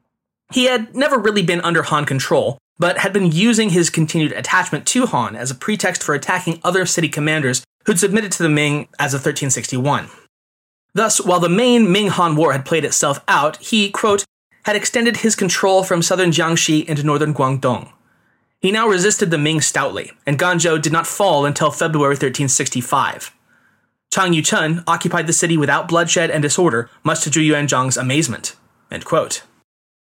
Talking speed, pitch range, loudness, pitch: 170 wpm, 145-190 Hz, -16 LUFS, 165 Hz